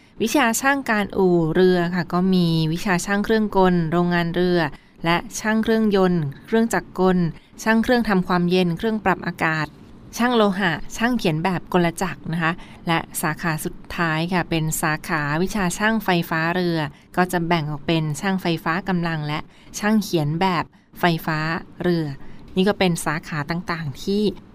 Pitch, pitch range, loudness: 175 Hz, 165-195 Hz, -21 LUFS